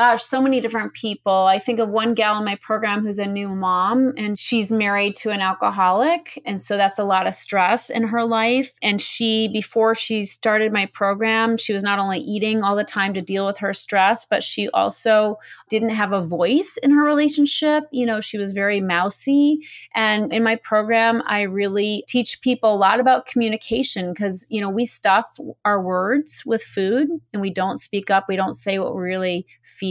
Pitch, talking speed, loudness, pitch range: 215 Hz, 205 wpm, -20 LUFS, 200-235 Hz